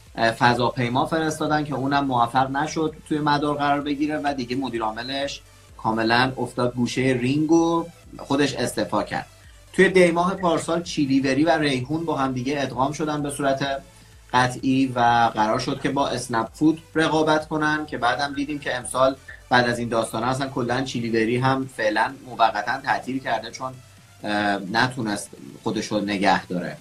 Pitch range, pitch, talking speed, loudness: 115-145 Hz, 130 Hz, 150 wpm, -23 LUFS